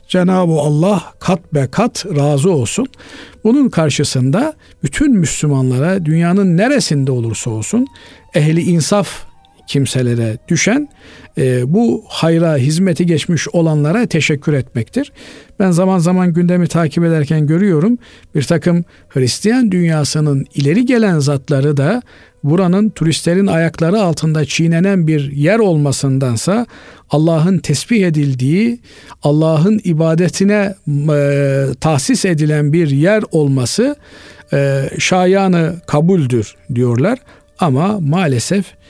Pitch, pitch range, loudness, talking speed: 165 Hz, 145-190 Hz, -14 LUFS, 100 wpm